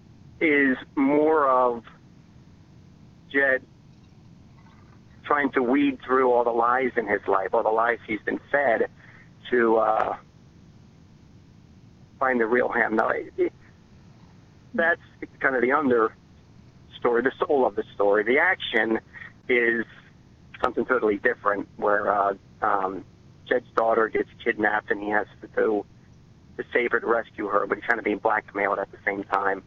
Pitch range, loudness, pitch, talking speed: 110-145 Hz, -24 LUFS, 125 Hz, 145 wpm